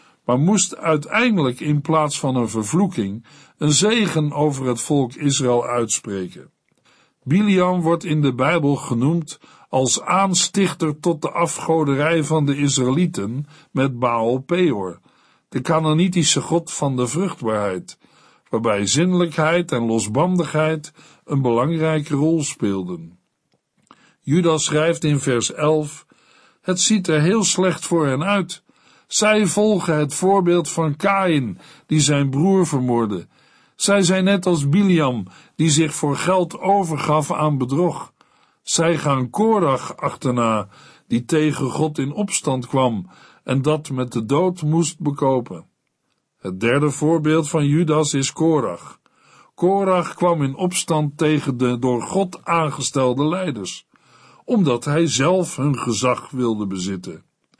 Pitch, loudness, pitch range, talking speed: 155 Hz, -19 LUFS, 130-175 Hz, 125 wpm